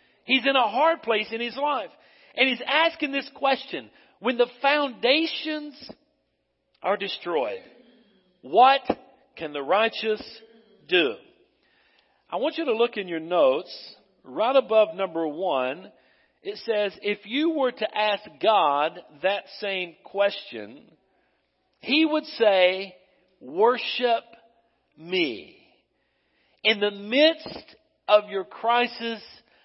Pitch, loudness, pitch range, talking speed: 235 Hz, -24 LUFS, 205-290 Hz, 115 wpm